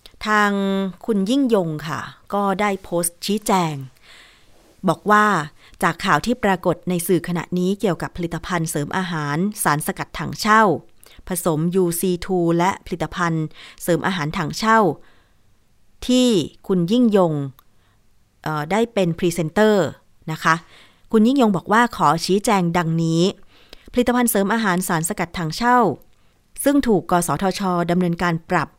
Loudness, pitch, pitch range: -20 LUFS, 180 Hz, 160-205 Hz